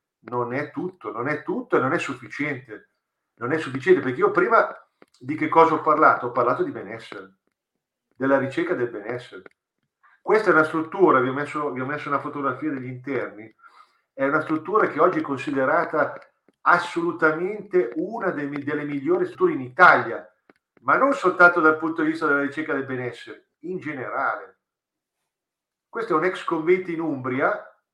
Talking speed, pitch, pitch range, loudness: 165 wpm, 155 Hz, 140-175 Hz, -22 LUFS